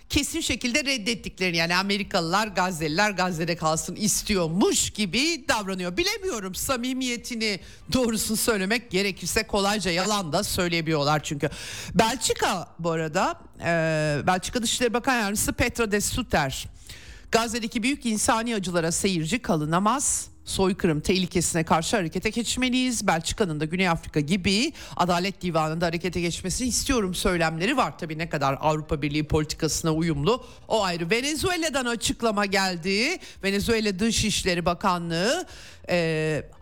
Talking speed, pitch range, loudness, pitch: 115 wpm, 170-230 Hz, -25 LUFS, 195 Hz